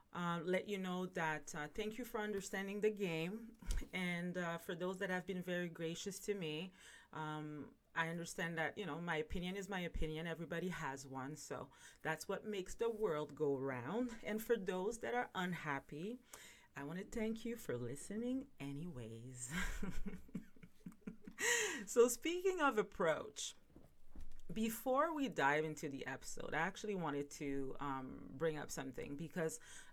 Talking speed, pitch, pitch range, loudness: 155 wpm, 180 Hz, 155-215 Hz, -42 LUFS